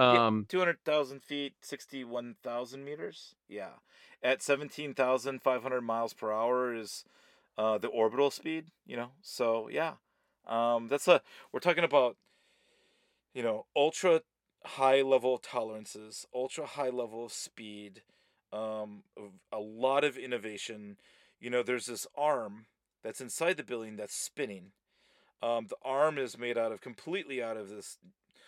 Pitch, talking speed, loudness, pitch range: 125 Hz, 135 wpm, -33 LUFS, 110-140 Hz